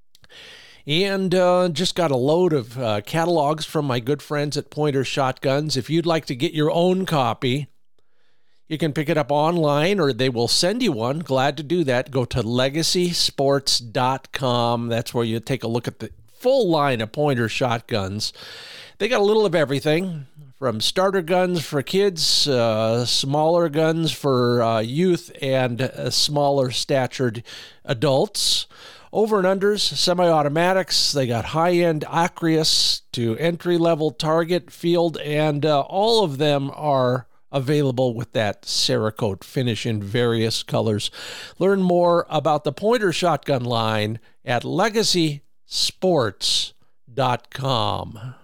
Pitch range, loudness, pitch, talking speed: 125-170 Hz, -21 LUFS, 145 Hz, 140 wpm